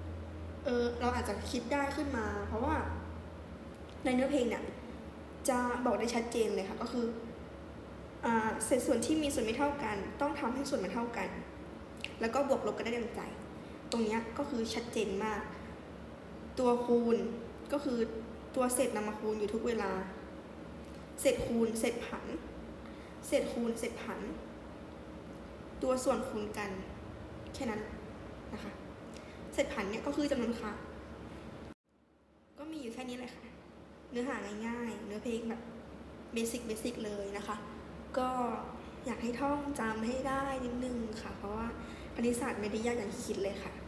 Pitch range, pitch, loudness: 220-255 Hz, 235 Hz, -36 LUFS